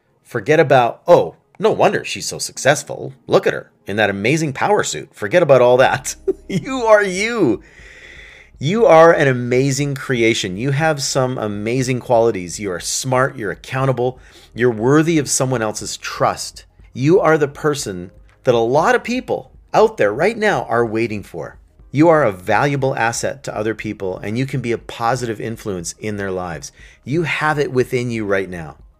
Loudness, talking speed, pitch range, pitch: -17 LUFS, 175 wpm, 105-145 Hz, 125 Hz